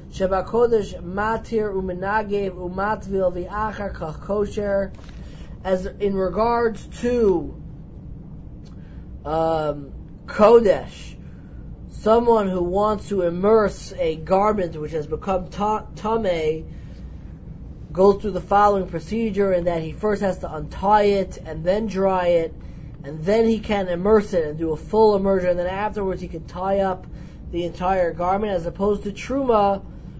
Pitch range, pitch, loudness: 175-210 Hz, 195 Hz, -21 LUFS